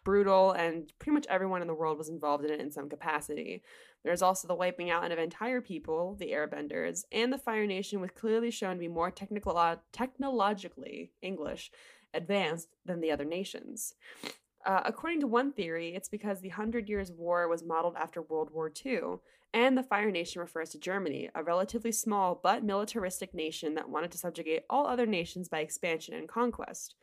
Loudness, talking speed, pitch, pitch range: -33 LUFS, 190 wpm, 180 Hz, 165-210 Hz